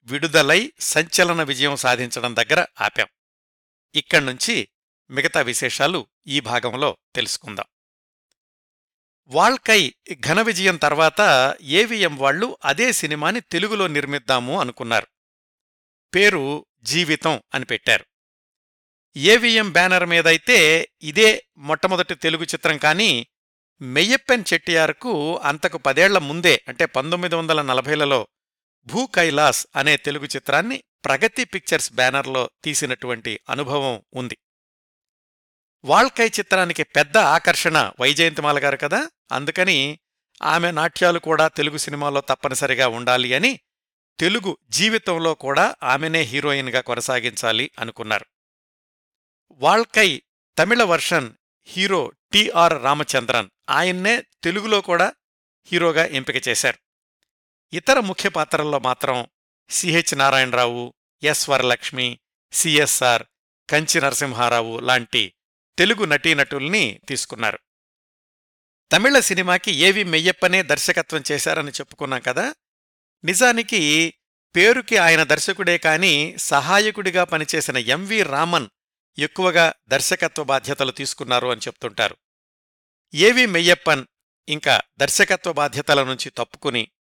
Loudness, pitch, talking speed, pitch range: -18 LUFS, 155 Hz, 90 wpm, 135-180 Hz